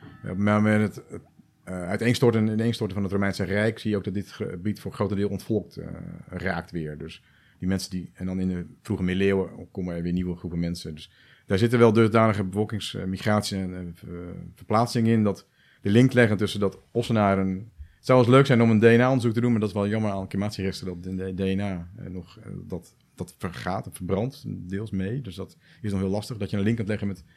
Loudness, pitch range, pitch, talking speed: -25 LUFS, 95-110 Hz, 100 Hz, 210 wpm